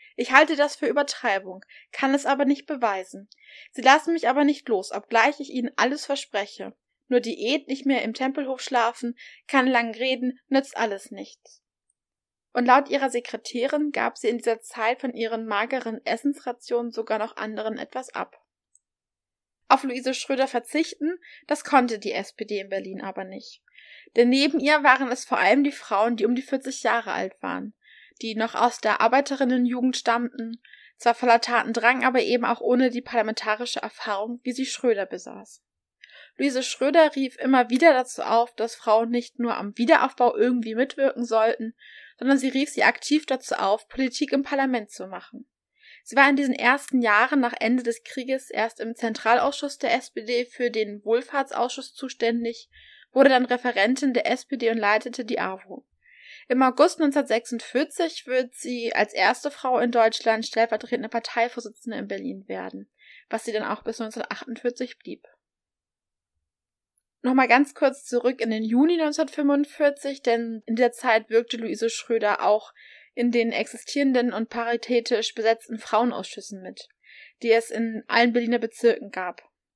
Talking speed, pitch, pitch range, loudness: 155 wpm, 245 Hz, 225-270 Hz, -24 LUFS